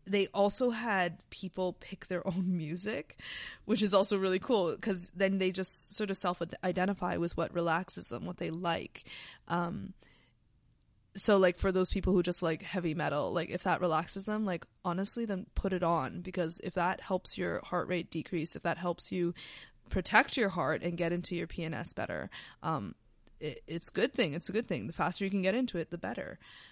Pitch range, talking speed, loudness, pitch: 170-195 Hz, 200 wpm, -33 LUFS, 180 Hz